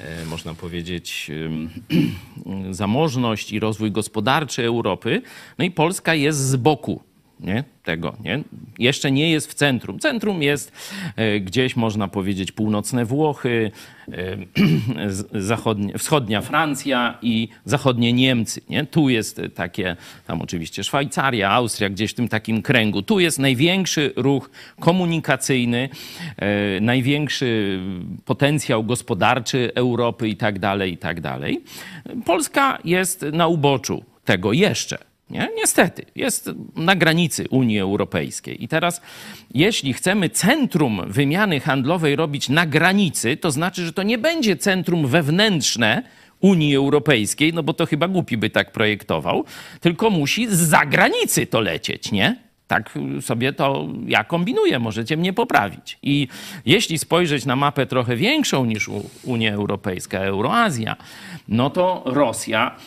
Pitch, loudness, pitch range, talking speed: 130 Hz, -20 LUFS, 110-160 Hz, 125 wpm